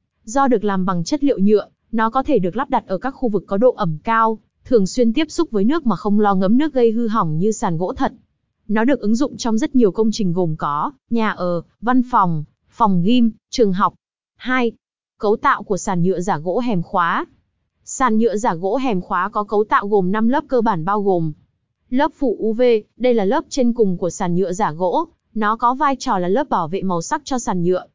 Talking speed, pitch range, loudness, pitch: 235 wpm, 190-250 Hz, -19 LUFS, 220 Hz